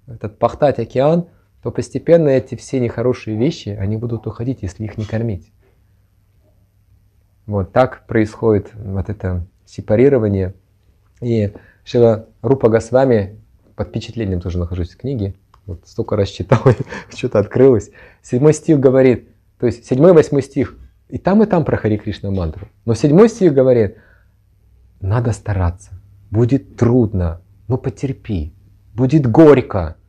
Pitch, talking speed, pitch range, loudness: 110 Hz, 130 wpm, 100-125 Hz, -16 LUFS